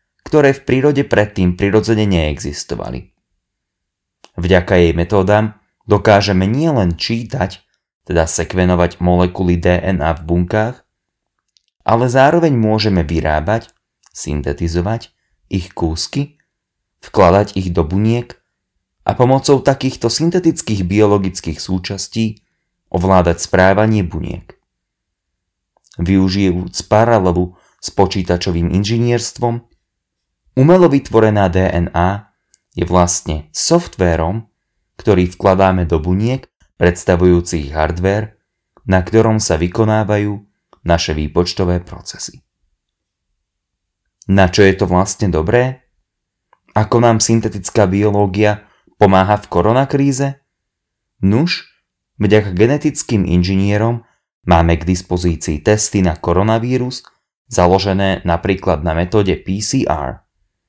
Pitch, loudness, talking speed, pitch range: 95 Hz, -15 LUFS, 90 wpm, 90-110 Hz